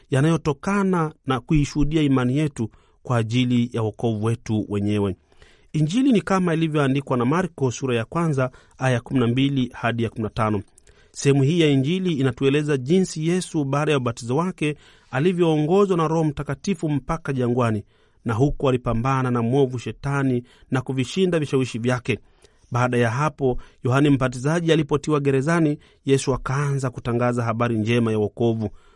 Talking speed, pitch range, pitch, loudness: 125 wpm, 120-155 Hz, 135 Hz, -22 LUFS